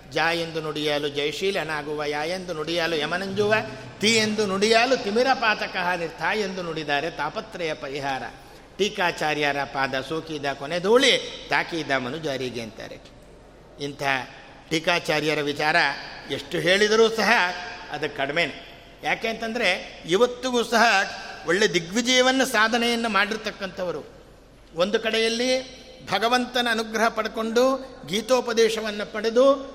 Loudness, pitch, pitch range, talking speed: -23 LUFS, 195 Hz, 155-230 Hz, 100 wpm